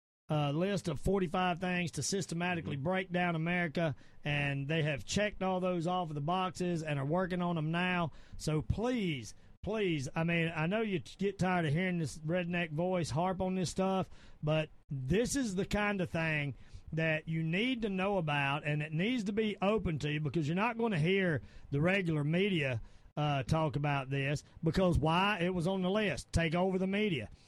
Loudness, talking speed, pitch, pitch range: -34 LUFS, 200 wpm, 170 Hz, 150-185 Hz